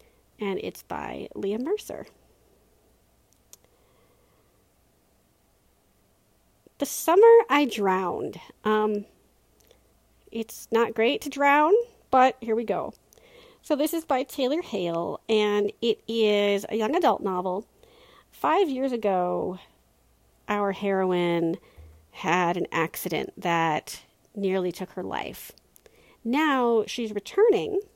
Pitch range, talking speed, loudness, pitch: 190-285 Hz, 105 wpm, -25 LUFS, 220 Hz